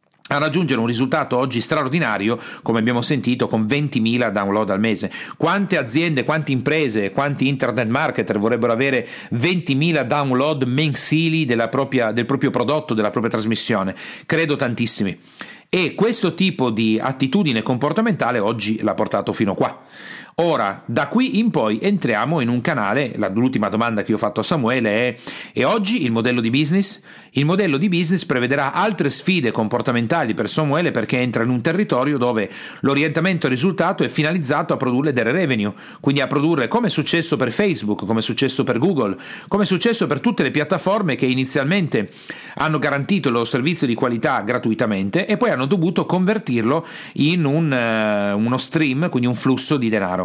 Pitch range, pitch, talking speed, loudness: 120-165 Hz, 140 Hz, 165 wpm, -19 LUFS